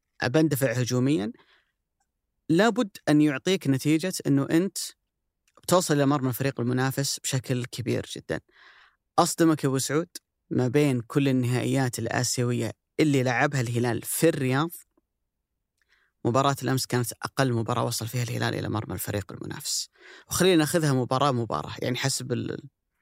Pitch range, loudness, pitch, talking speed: 125-150 Hz, -26 LUFS, 135 Hz, 120 wpm